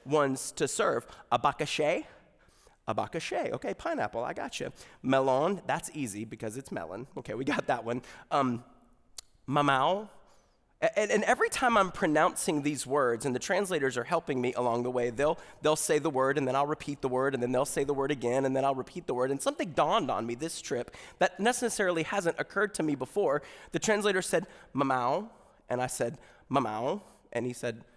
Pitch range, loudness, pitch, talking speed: 125-165 Hz, -30 LUFS, 140 Hz, 195 wpm